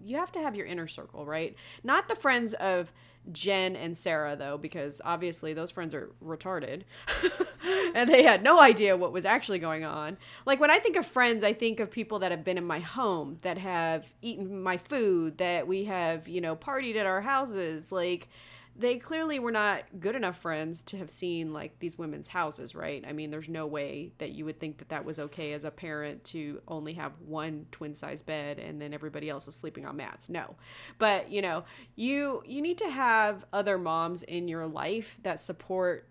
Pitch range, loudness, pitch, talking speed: 155-210 Hz, -29 LUFS, 175 Hz, 210 wpm